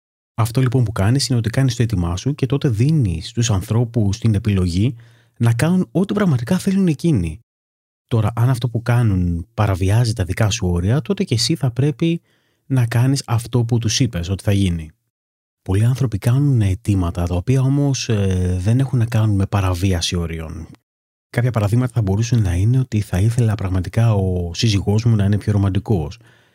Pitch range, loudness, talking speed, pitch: 95-125 Hz, -18 LUFS, 180 wpm, 115 Hz